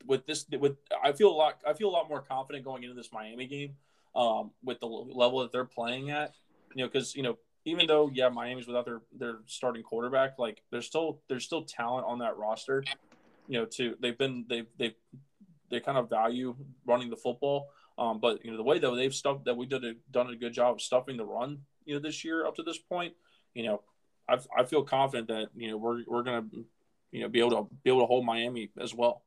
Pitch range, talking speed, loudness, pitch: 120-140 Hz, 240 wpm, -32 LUFS, 125 Hz